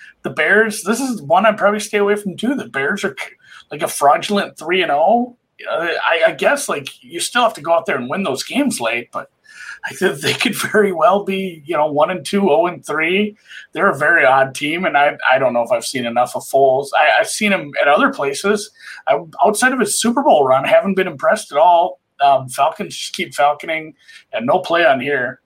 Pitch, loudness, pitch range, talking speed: 200 Hz, -16 LUFS, 150-220 Hz, 225 wpm